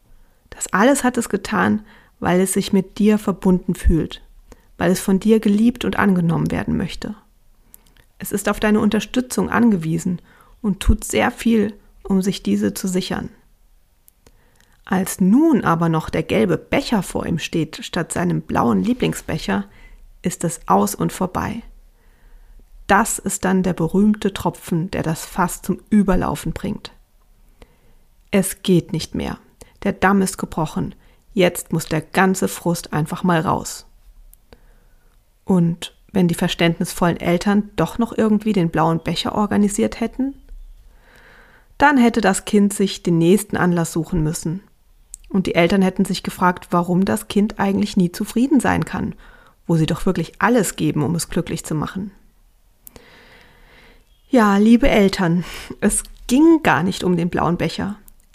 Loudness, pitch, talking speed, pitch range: -19 LUFS, 190 Hz, 145 wpm, 170-210 Hz